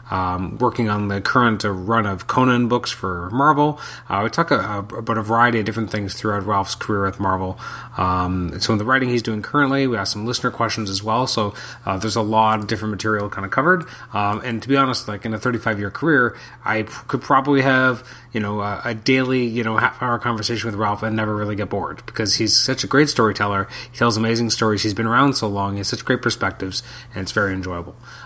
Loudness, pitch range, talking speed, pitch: -20 LUFS, 100-120 Hz, 235 wpm, 110 Hz